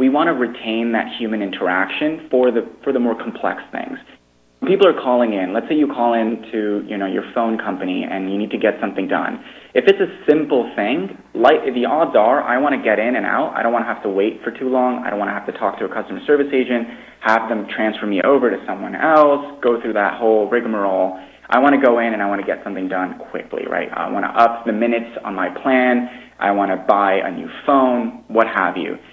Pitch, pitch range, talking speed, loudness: 115 Hz, 105-125 Hz, 245 wpm, -18 LUFS